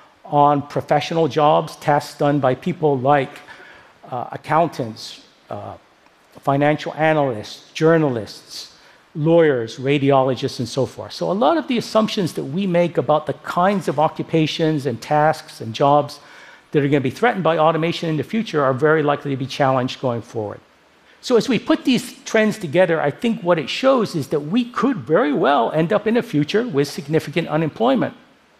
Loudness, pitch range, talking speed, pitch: -19 LUFS, 140-175 Hz, 170 wpm, 155 Hz